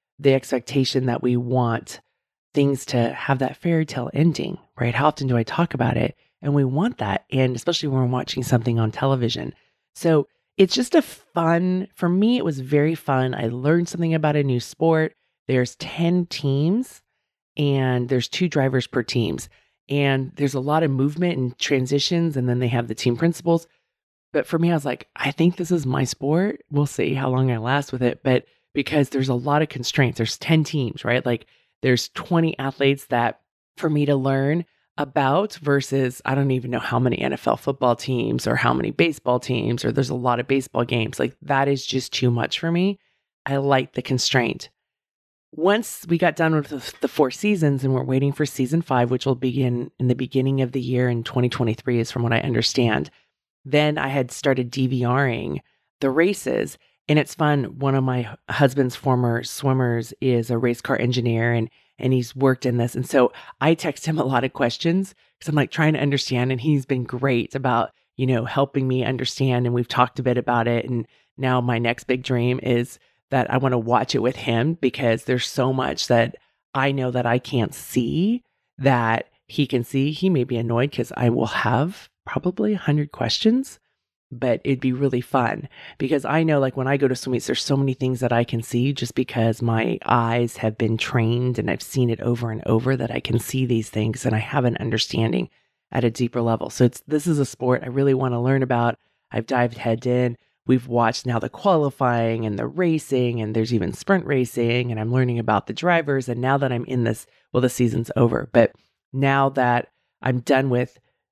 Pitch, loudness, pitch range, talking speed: 130 Hz, -22 LUFS, 120-145 Hz, 205 wpm